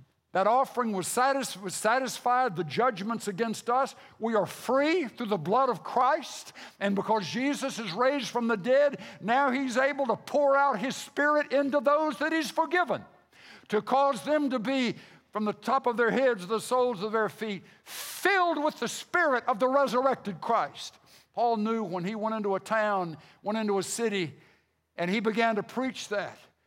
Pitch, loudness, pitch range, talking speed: 235 Hz, -28 LUFS, 210-270 Hz, 180 wpm